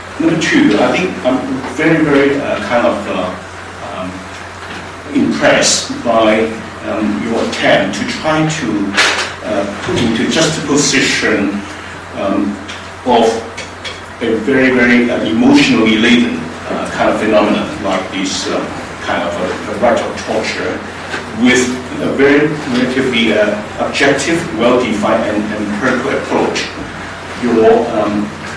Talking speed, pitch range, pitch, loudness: 130 wpm, 95-130 Hz, 110 Hz, -13 LUFS